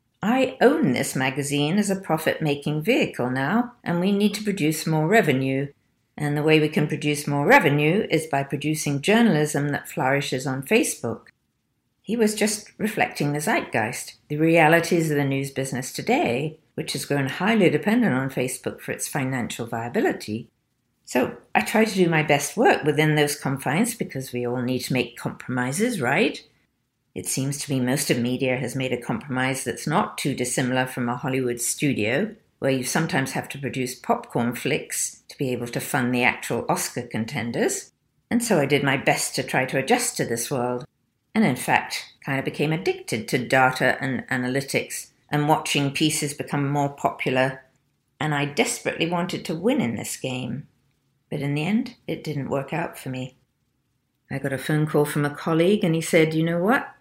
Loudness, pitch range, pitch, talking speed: -23 LUFS, 130-165 Hz, 145 Hz, 185 wpm